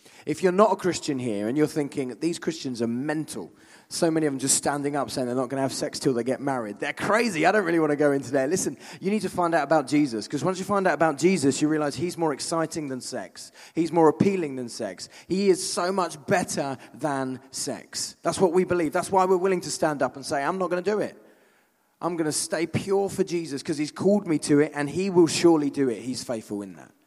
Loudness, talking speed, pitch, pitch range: -25 LUFS, 260 wpm, 155 Hz, 135-180 Hz